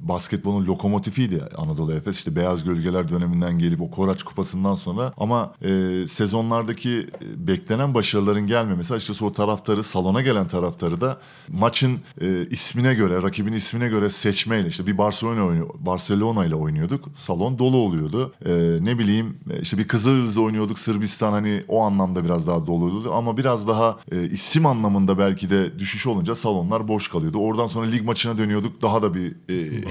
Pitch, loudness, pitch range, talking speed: 105 Hz, -22 LUFS, 95-115 Hz, 160 wpm